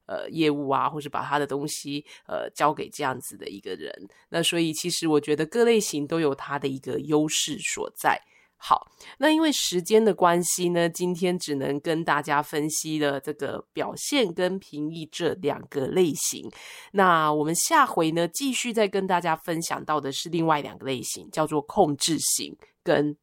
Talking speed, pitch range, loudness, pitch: 265 characters per minute, 145-180 Hz, -25 LUFS, 160 Hz